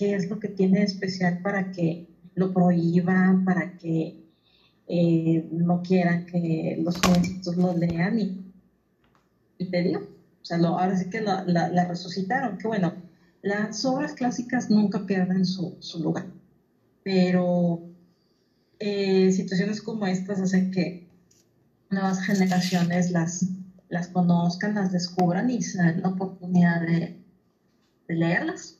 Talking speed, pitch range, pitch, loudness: 135 wpm, 175-195 Hz, 185 Hz, -25 LUFS